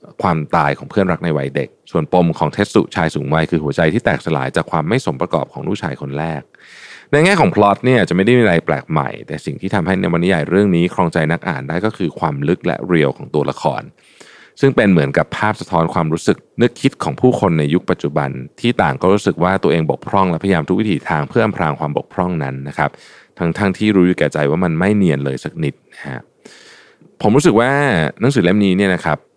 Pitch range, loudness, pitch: 75-100 Hz, -16 LUFS, 85 Hz